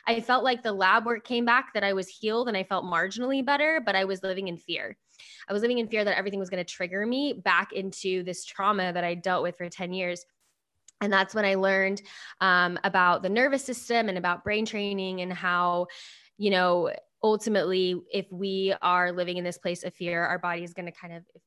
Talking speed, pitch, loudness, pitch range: 225 wpm, 190 Hz, -27 LUFS, 180-210 Hz